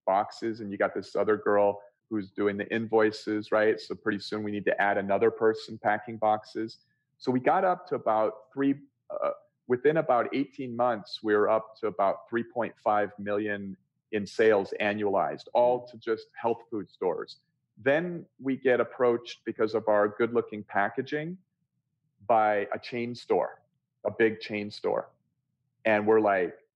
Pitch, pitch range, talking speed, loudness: 110 Hz, 105-130 Hz, 160 wpm, -28 LUFS